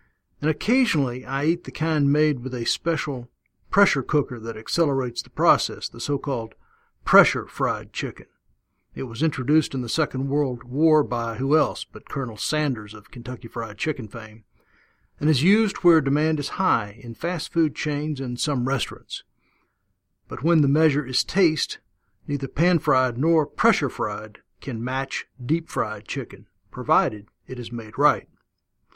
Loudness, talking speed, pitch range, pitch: -23 LUFS, 155 wpm, 120-155 Hz, 140 Hz